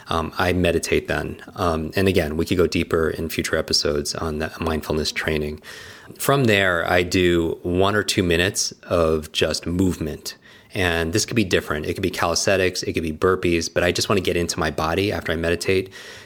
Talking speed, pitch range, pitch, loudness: 200 wpm, 80-95 Hz, 85 Hz, -21 LUFS